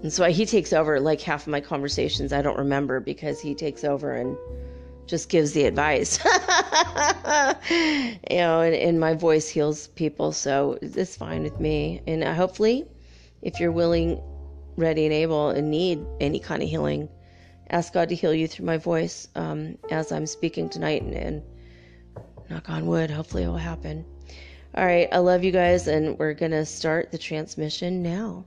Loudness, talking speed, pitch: -24 LUFS, 180 wpm, 155 Hz